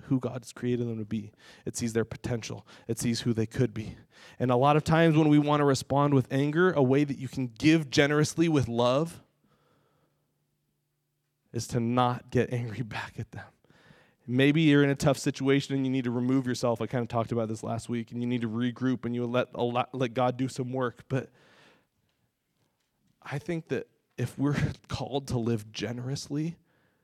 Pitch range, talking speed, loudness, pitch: 120-140 Hz, 195 wpm, -28 LUFS, 125 Hz